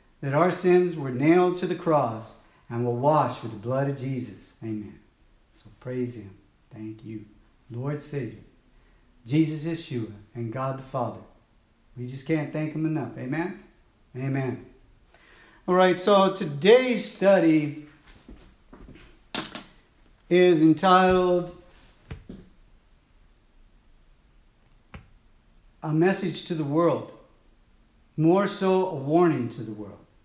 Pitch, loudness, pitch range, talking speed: 140 Hz, -24 LUFS, 115-170 Hz, 115 wpm